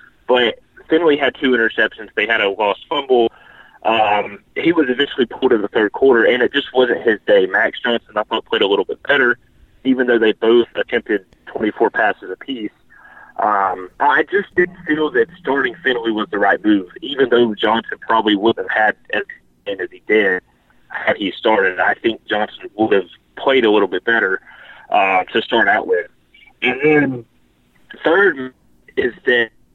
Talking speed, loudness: 180 wpm, -16 LUFS